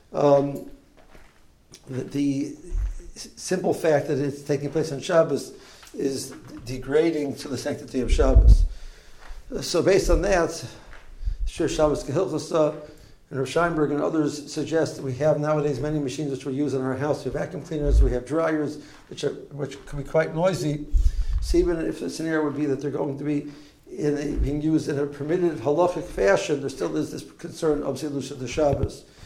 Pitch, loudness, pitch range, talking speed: 145 Hz, -25 LUFS, 140-155 Hz, 175 wpm